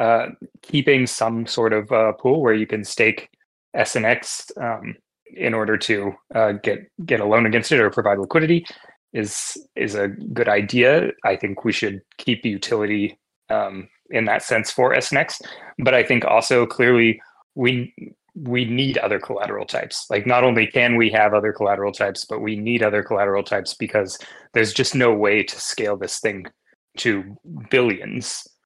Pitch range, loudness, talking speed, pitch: 105-125 Hz, -20 LUFS, 170 wpm, 110 Hz